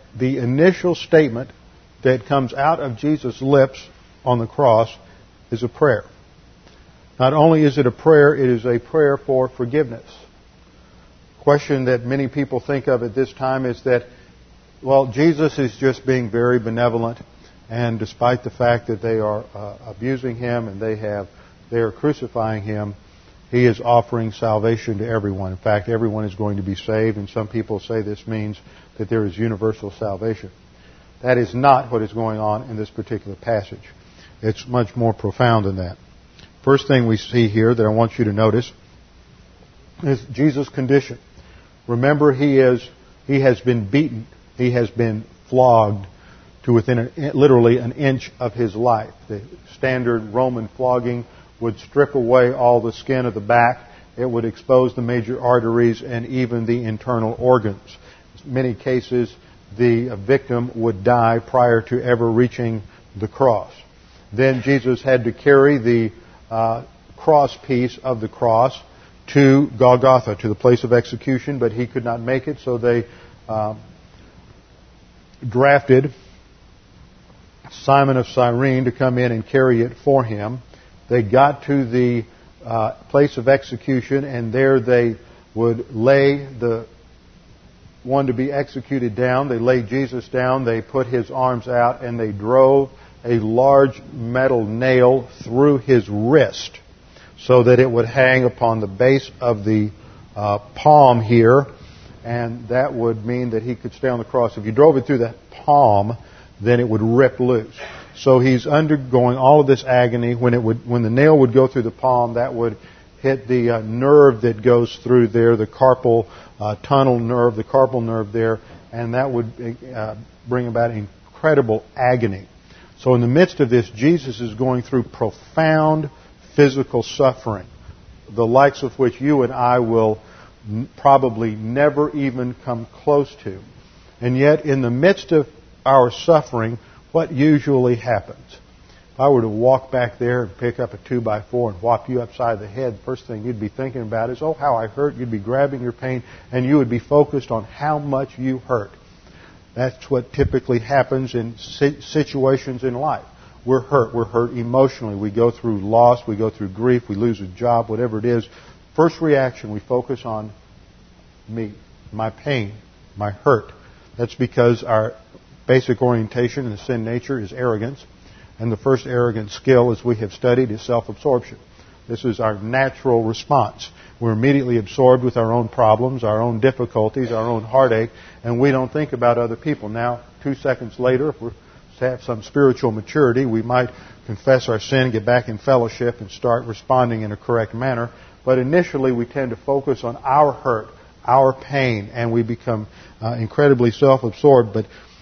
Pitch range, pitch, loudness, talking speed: 110-130 Hz, 120 Hz, -18 LUFS, 170 wpm